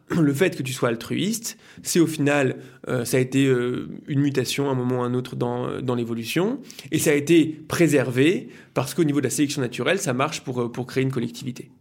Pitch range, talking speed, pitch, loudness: 125-155 Hz, 235 wpm, 135 Hz, -23 LUFS